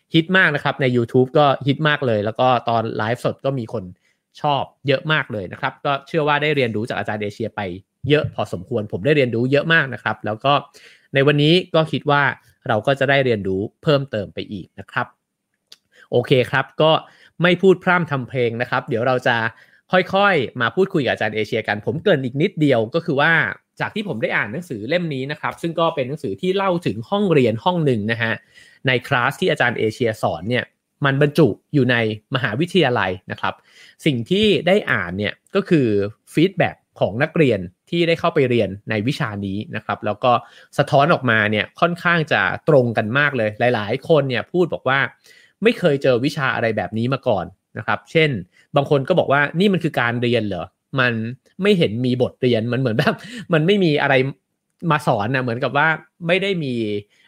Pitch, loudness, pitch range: 135 Hz, -19 LUFS, 115-160 Hz